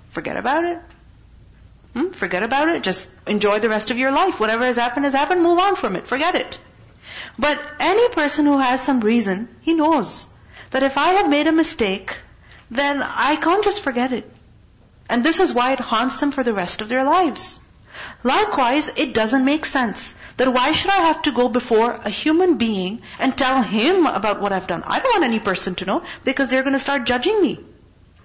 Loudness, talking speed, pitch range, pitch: -19 LUFS, 205 wpm, 225-315 Hz, 265 Hz